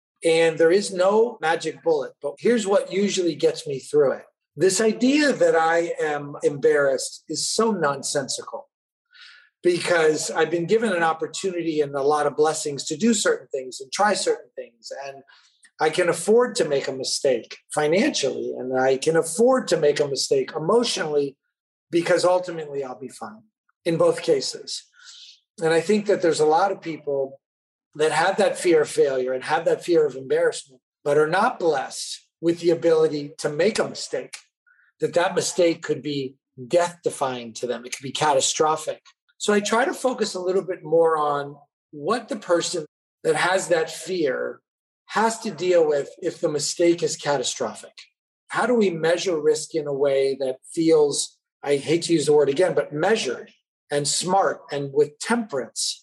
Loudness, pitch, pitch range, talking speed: -22 LUFS, 175 Hz, 150-240 Hz, 175 wpm